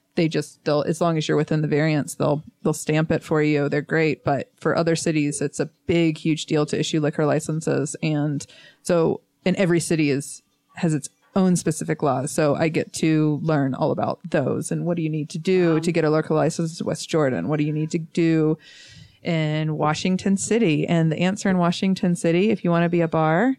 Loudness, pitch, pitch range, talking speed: -22 LUFS, 160 Hz, 150-170 Hz, 220 wpm